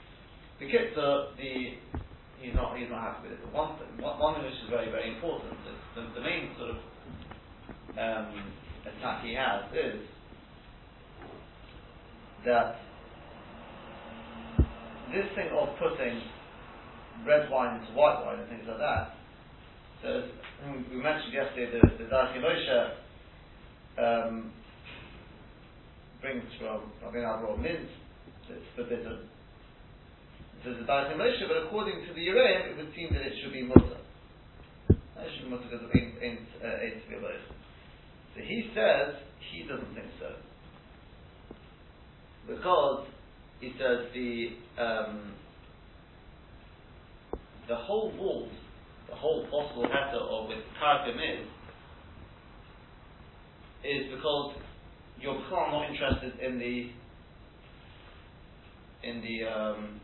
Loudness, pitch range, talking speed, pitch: -31 LUFS, 105-135 Hz, 115 wpm, 120 Hz